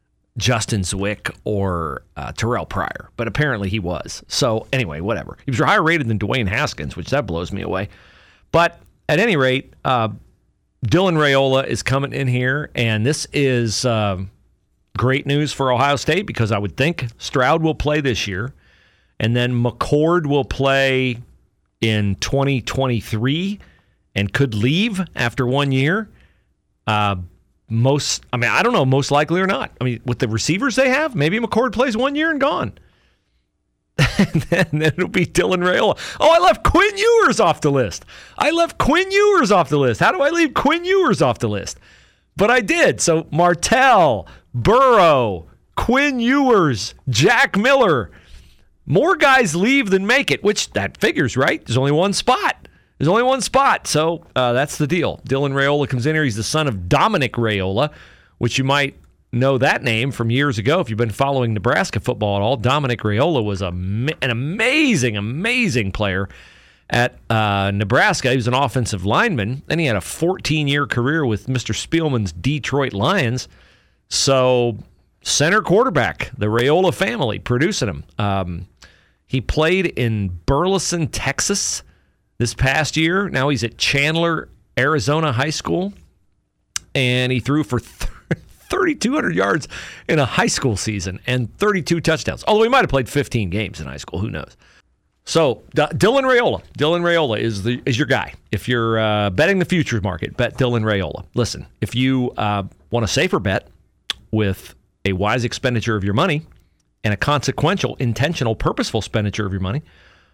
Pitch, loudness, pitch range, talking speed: 130 Hz, -18 LUFS, 110-165 Hz, 165 wpm